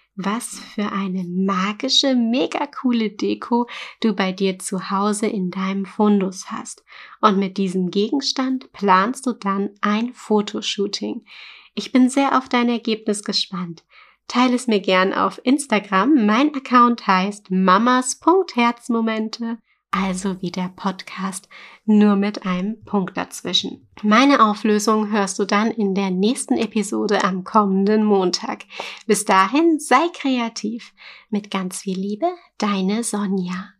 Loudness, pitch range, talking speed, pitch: -20 LUFS, 195-240 Hz, 130 wpm, 210 Hz